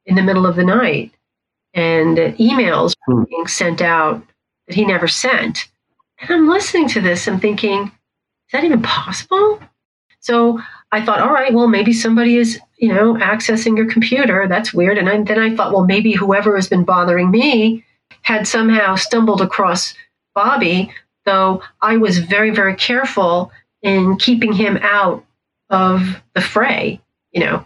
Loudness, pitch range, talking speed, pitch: -14 LUFS, 190-230 Hz, 165 wpm, 210 Hz